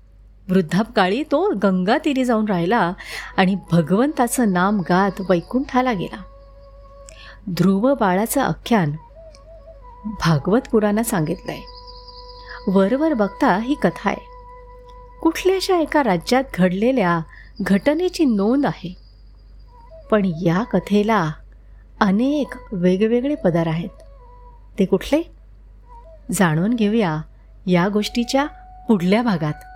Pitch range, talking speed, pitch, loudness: 180-275 Hz, 90 wpm, 210 Hz, -19 LUFS